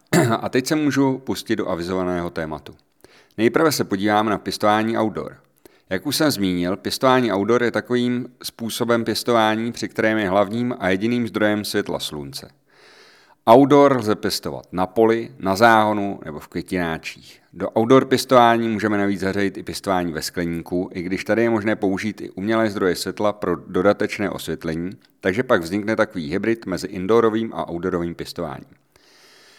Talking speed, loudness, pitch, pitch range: 155 wpm, -20 LUFS, 105 Hz, 90-115 Hz